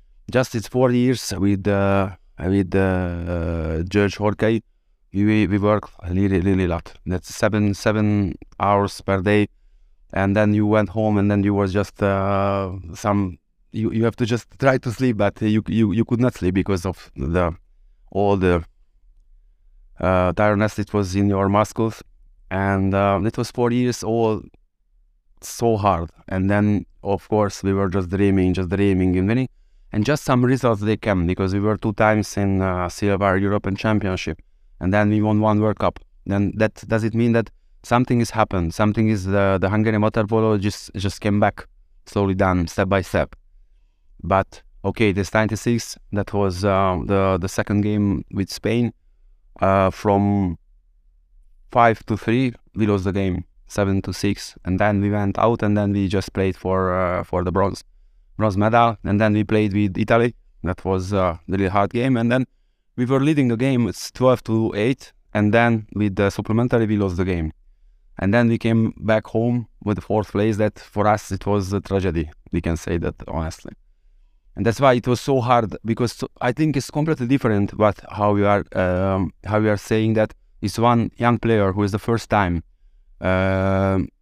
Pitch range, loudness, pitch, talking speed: 90-110 Hz, -21 LUFS, 100 Hz, 185 wpm